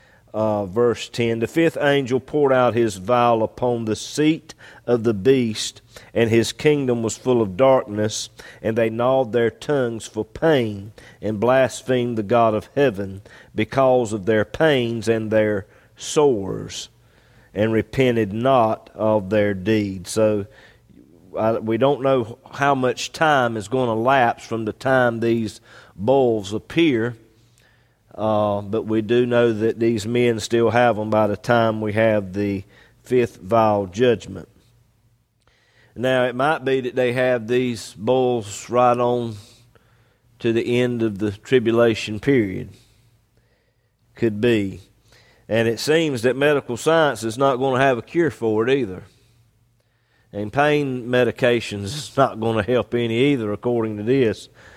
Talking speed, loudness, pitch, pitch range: 150 wpm, -20 LUFS, 115 Hz, 110-125 Hz